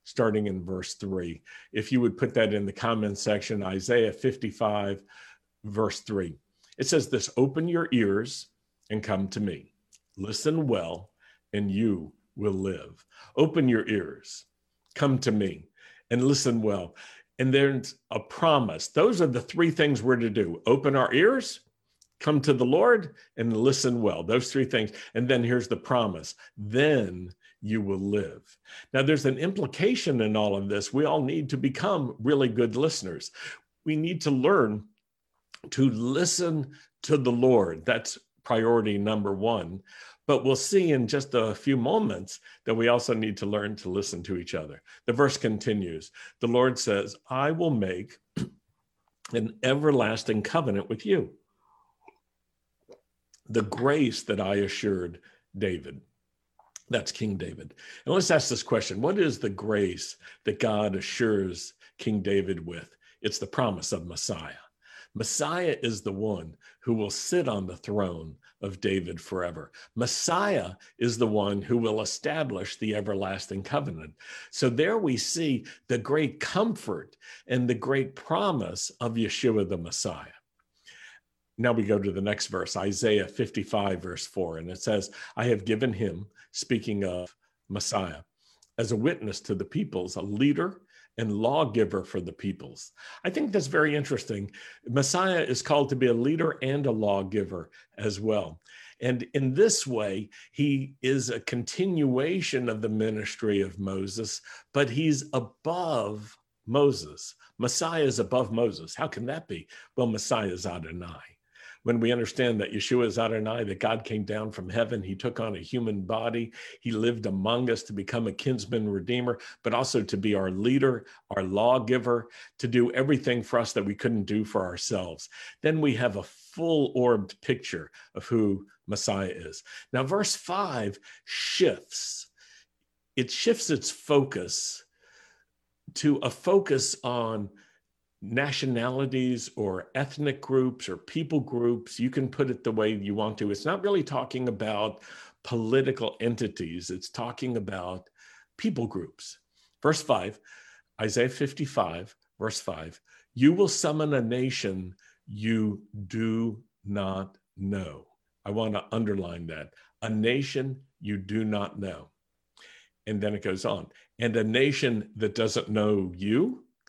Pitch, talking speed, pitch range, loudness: 115 Hz, 150 wpm, 100-130 Hz, -28 LUFS